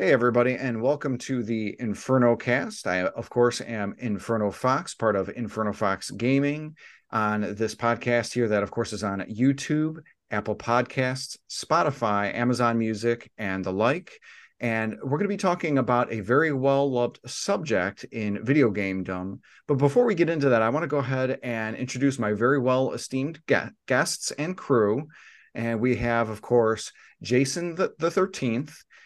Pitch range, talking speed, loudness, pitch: 110-140 Hz, 165 wpm, -26 LUFS, 120 Hz